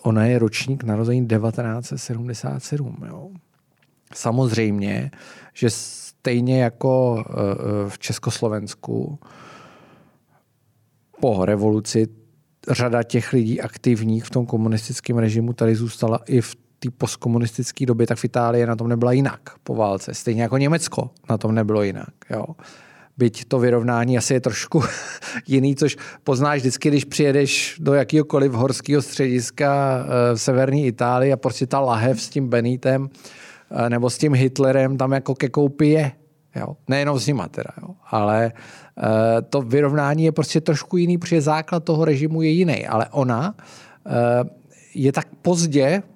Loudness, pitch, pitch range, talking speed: -20 LUFS, 130 Hz, 115-145 Hz, 135 wpm